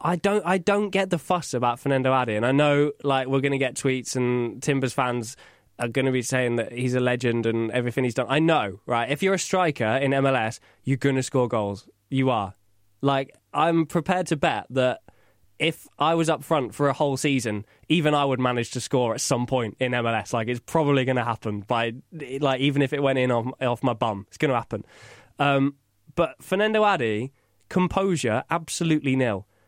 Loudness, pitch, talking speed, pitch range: -24 LUFS, 130 Hz, 200 wpm, 120-150 Hz